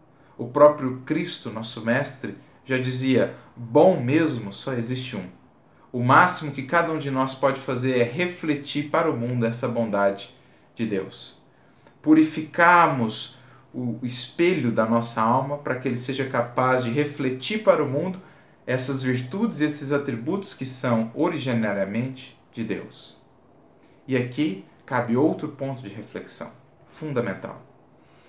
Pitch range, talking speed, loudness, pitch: 120-150 Hz, 135 wpm, -23 LUFS, 130 Hz